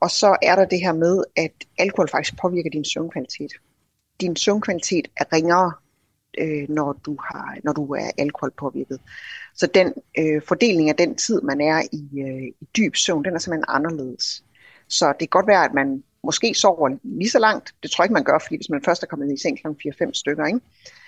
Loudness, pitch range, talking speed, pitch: -21 LUFS, 140-180 Hz, 215 wpm, 155 Hz